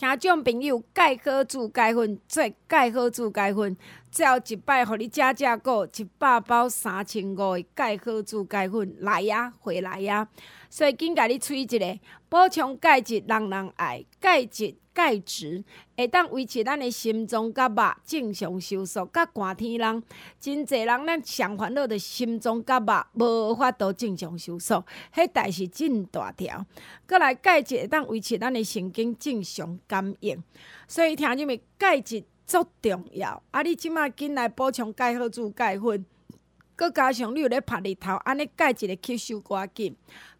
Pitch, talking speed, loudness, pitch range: 235 Hz, 240 characters per minute, -25 LUFS, 205-265 Hz